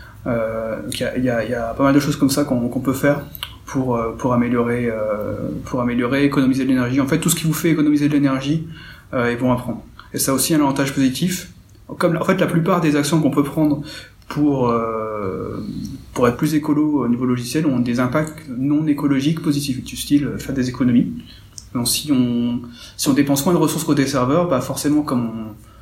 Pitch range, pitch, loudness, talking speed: 120-150 Hz, 135 Hz, -19 LUFS, 205 wpm